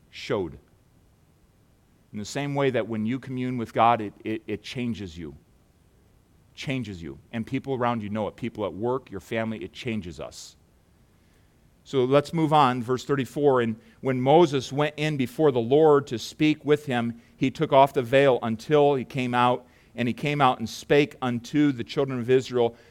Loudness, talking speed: -25 LUFS, 185 wpm